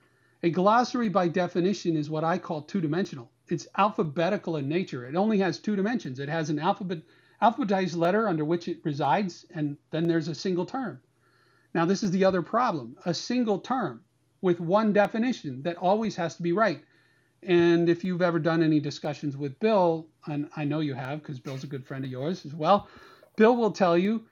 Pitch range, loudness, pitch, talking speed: 155-195 Hz, -27 LUFS, 170 Hz, 195 wpm